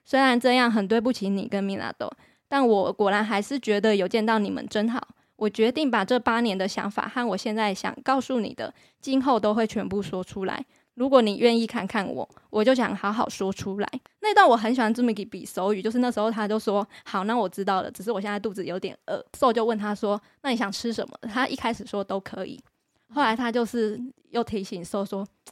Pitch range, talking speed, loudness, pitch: 205-245 Hz, 320 characters per minute, -25 LUFS, 220 Hz